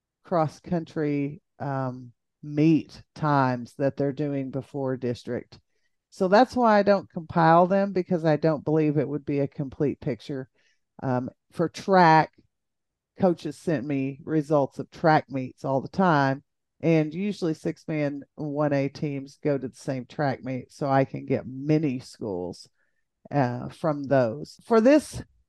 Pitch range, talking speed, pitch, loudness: 135-165 Hz, 150 wpm, 150 Hz, -25 LUFS